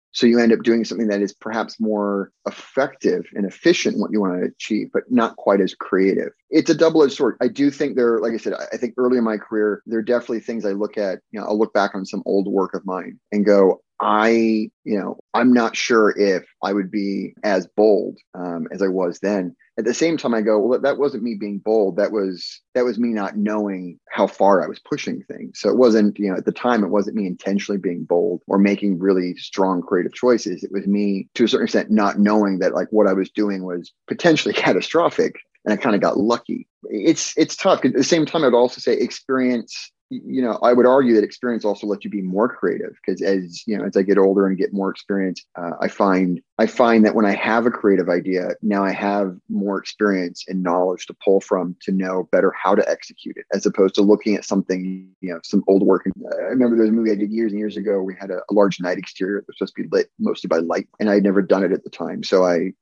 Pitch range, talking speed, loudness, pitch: 95-115 Hz, 250 wpm, -19 LUFS, 100 Hz